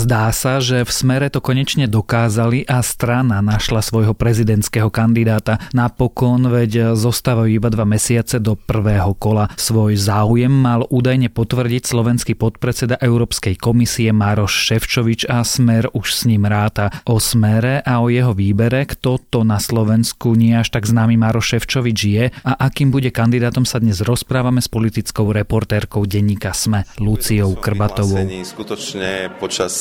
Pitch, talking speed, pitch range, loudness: 115 Hz, 145 wpm, 110-125 Hz, -16 LUFS